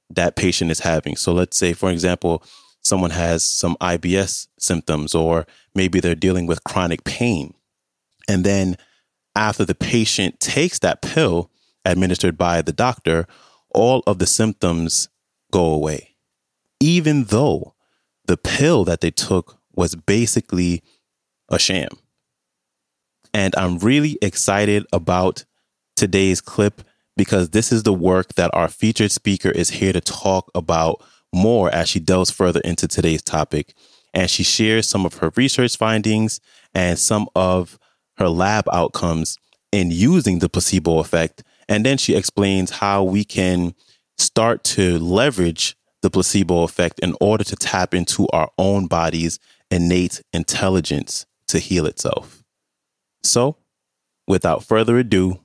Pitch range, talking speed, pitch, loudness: 85-100 Hz, 140 wpm, 90 Hz, -18 LUFS